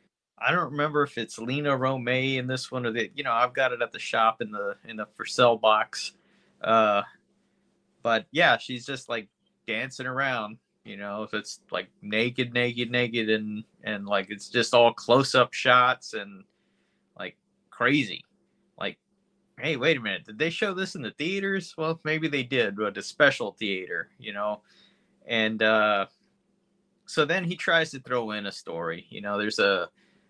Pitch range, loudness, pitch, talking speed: 110-160 Hz, -26 LUFS, 125 Hz, 180 wpm